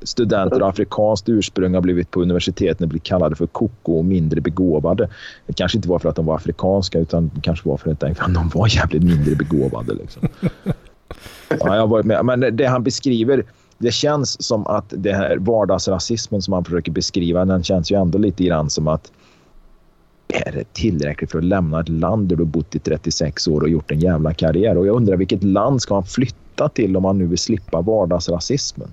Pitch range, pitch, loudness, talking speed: 85-100 Hz, 90 Hz, -18 LUFS, 205 wpm